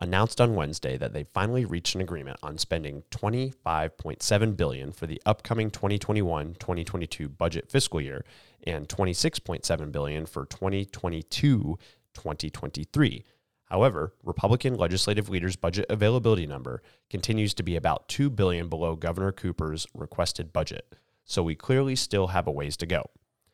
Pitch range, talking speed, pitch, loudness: 80-105 Hz, 135 wpm, 90 Hz, -28 LUFS